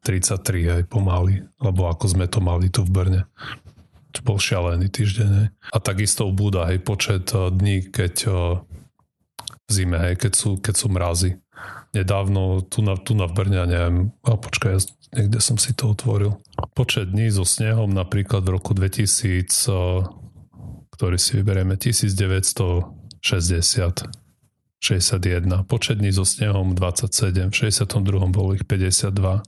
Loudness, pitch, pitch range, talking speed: -21 LUFS, 100 Hz, 95-110 Hz, 145 wpm